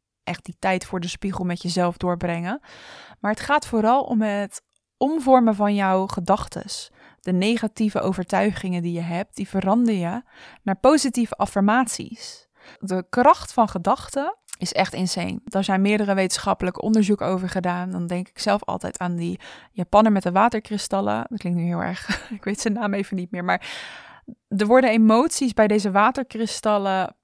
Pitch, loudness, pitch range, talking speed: 200 Hz, -22 LUFS, 185-225 Hz, 165 wpm